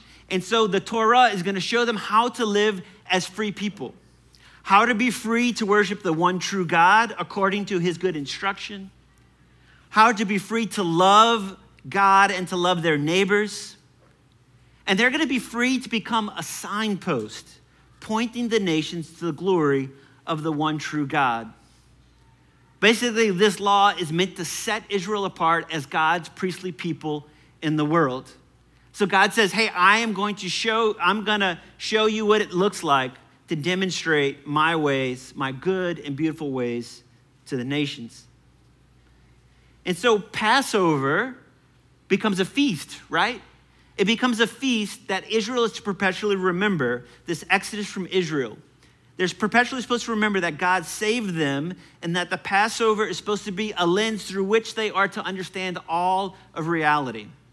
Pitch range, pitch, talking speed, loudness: 150-210 Hz, 185 Hz, 165 wpm, -22 LUFS